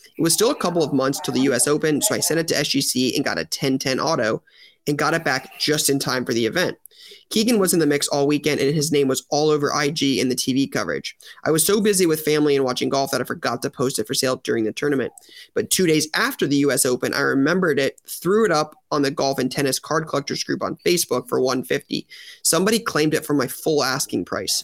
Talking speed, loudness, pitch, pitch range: 250 wpm, -20 LUFS, 145 Hz, 135-155 Hz